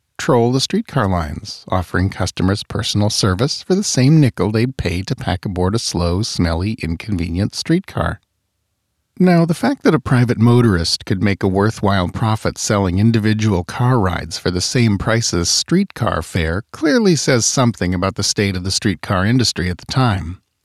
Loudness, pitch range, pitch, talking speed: -17 LUFS, 95-120 Hz, 105 Hz, 170 wpm